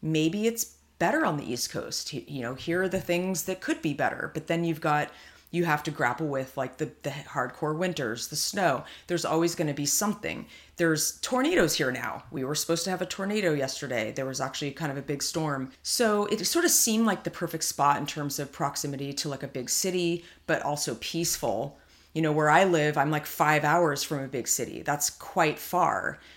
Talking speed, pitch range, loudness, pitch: 220 wpm, 140-175 Hz, -28 LUFS, 155 Hz